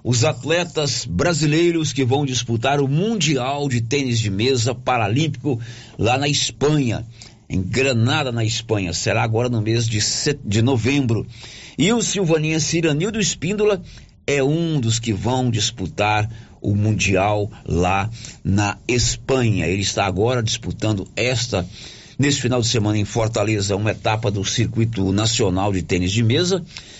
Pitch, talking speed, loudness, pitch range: 120 Hz, 140 wpm, -20 LUFS, 105-140 Hz